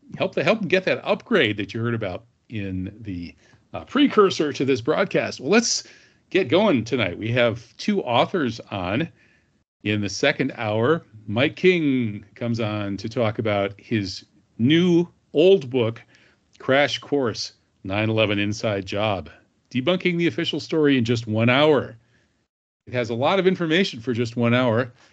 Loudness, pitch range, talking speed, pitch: -22 LUFS, 110-155 Hz, 160 wpm, 120 Hz